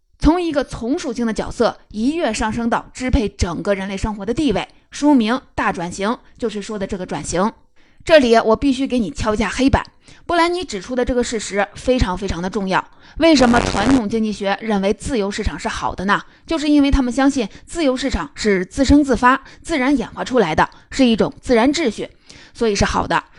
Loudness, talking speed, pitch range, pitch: -18 LUFS, 310 characters per minute, 210-275 Hz, 240 Hz